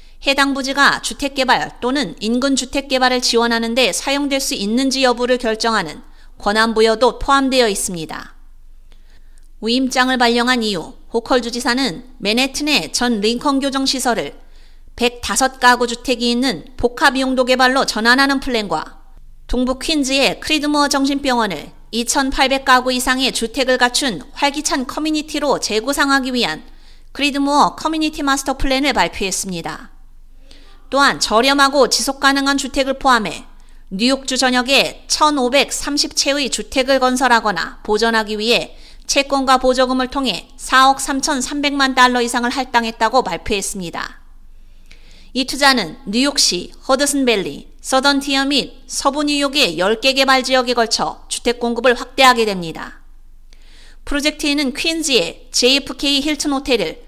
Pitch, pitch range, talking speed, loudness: 260 Hz, 240-275 Hz, 300 characters per minute, -16 LUFS